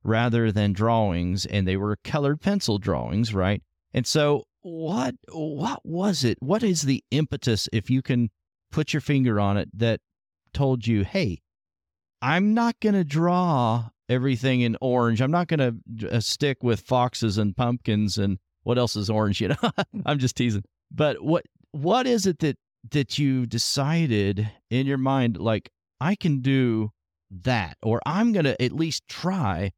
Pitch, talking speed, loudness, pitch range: 125 Hz, 170 wpm, -24 LUFS, 105-150 Hz